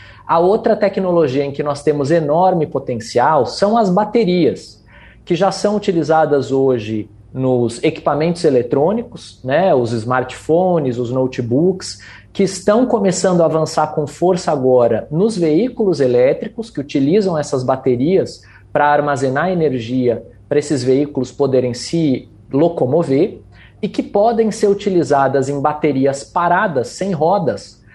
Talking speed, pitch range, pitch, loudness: 125 wpm, 130-185 Hz, 150 Hz, -16 LUFS